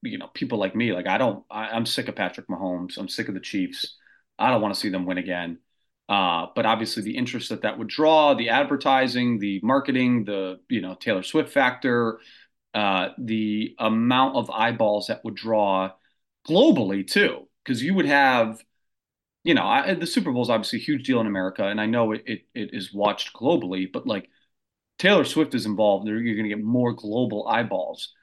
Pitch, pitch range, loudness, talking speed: 110 Hz, 100-125 Hz, -23 LUFS, 200 wpm